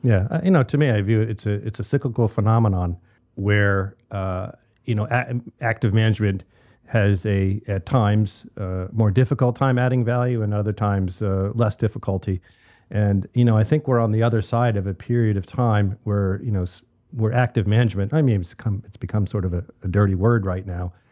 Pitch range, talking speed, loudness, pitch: 100-120 Hz, 205 wpm, -22 LUFS, 110 Hz